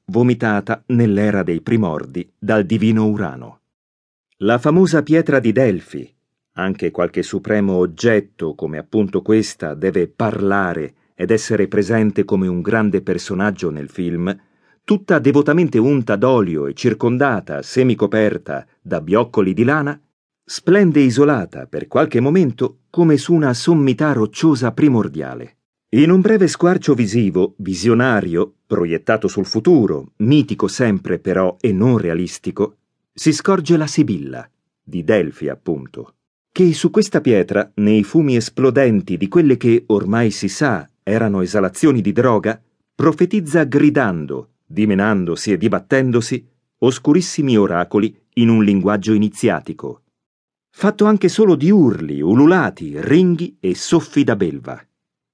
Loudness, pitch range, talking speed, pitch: -16 LUFS, 100-150 Hz, 125 wpm, 115 Hz